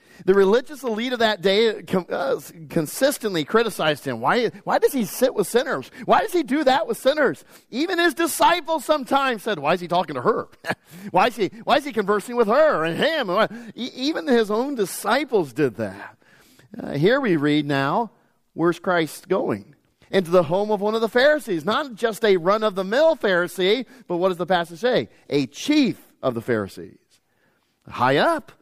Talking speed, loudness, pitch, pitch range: 185 wpm, -21 LUFS, 215 Hz, 180-260 Hz